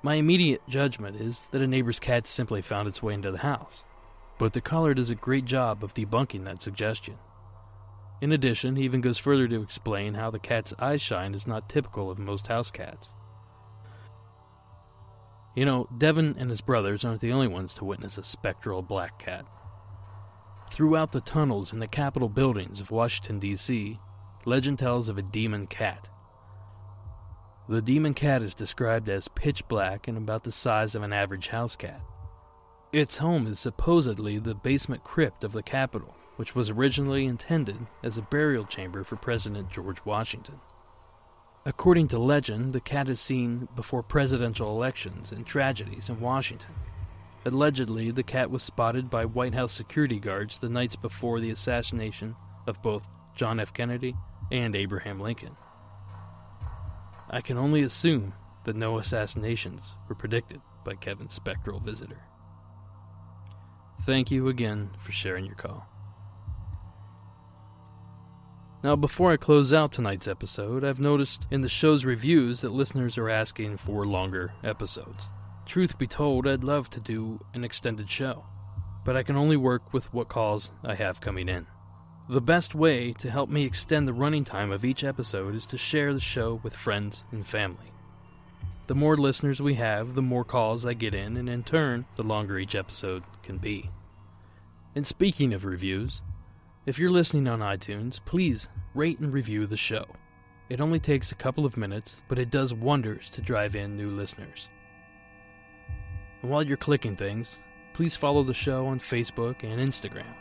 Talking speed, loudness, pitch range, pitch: 165 wpm, -28 LUFS, 100-130 Hz, 110 Hz